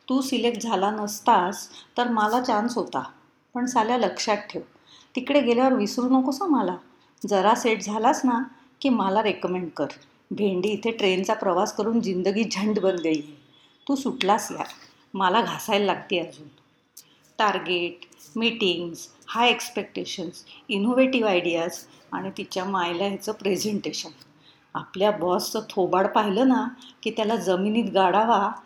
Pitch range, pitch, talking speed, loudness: 185-235 Hz, 210 Hz, 130 wpm, -24 LUFS